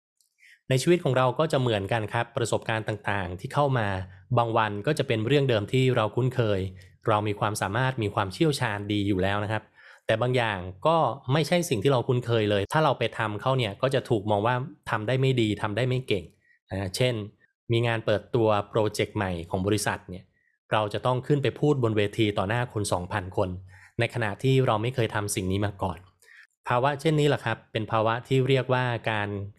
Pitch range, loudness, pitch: 105-130 Hz, -26 LUFS, 115 Hz